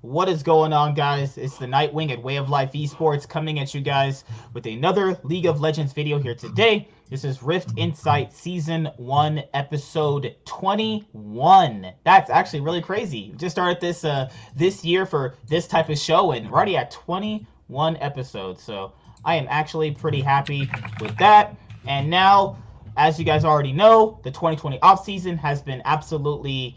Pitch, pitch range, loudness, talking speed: 150 Hz, 135-170 Hz, -21 LUFS, 175 wpm